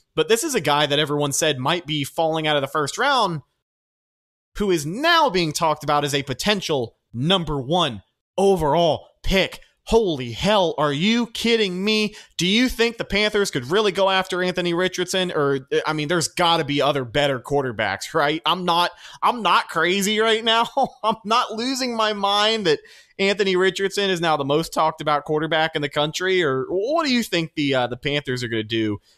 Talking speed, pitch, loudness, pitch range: 195 wpm, 170 Hz, -21 LUFS, 145-205 Hz